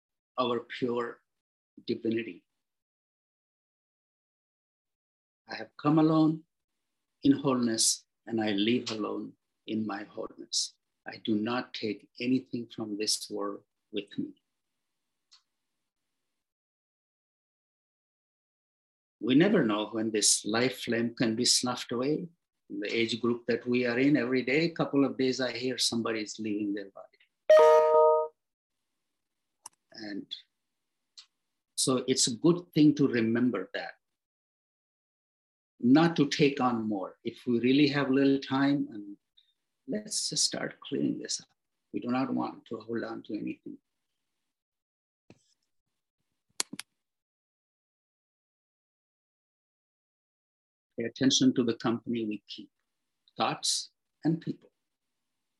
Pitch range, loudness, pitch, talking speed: 115-145 Hz, -28 LUFS, 125 Hz, 110 wpm